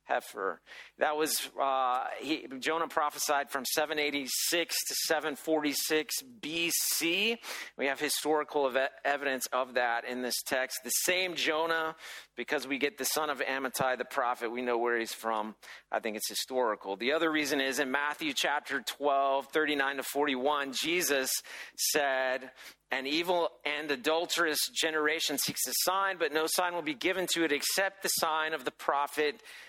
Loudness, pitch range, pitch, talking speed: -31 LUFS, 130-160 Hz, 145 Hz, 160 wpm